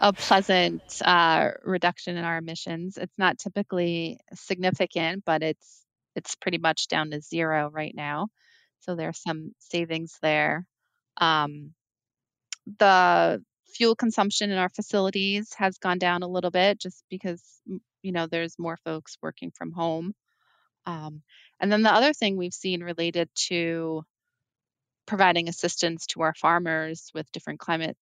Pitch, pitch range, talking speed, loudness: 175 Hz, 160-195 Hz, 145 wpm, -25 LUFS